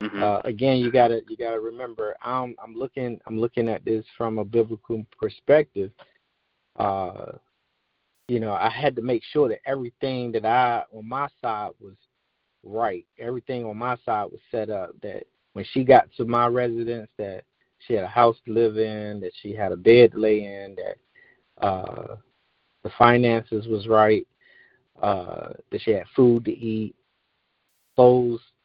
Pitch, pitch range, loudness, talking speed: 115 Hz, 110-125 Hz, -23 LUFS, 165 wpm